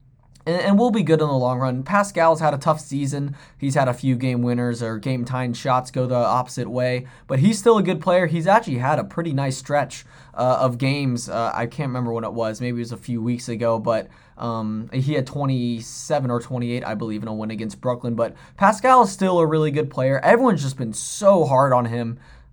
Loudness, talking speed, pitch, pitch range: -21 LUFS, 230 wpm, 130 Hz, 120-150 Hz